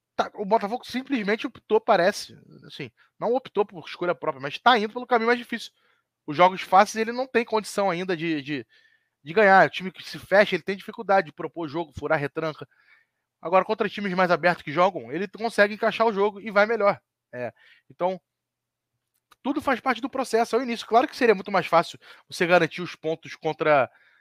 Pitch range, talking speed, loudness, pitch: 160-230 Hz, 195 wpm, -24 LUFS, 195 Hz